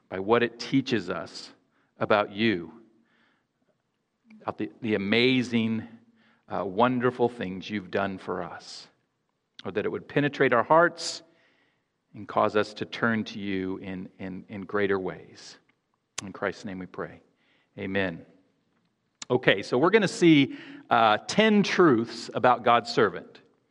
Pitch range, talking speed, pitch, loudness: 100-135 Hz, 140 wpm, 115 Hz, -25 LUFS